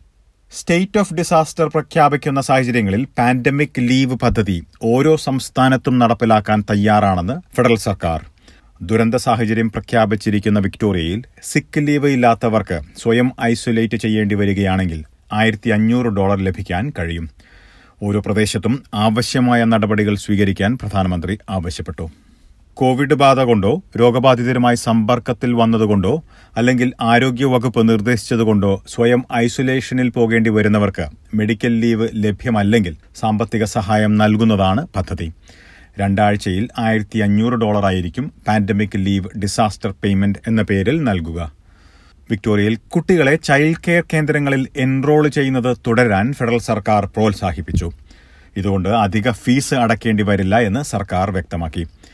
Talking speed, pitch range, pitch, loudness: 100 wpm, 100-125 Hz, 110 Hz, -16 LUFS